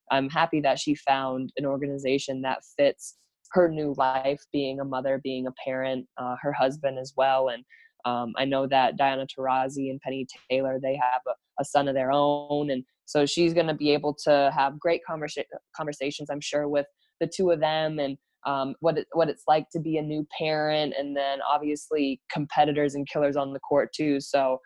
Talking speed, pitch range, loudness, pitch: 200 wpm, 135-150 Hz, -27 LUFS, 140 Hz